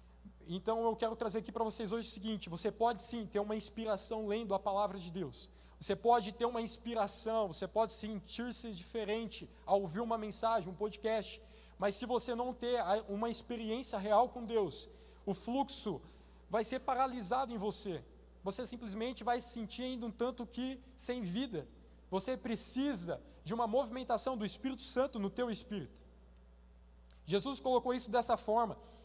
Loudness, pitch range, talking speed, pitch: -36 LUFS, 200-240 Hz, 165 wpm, 225 Hz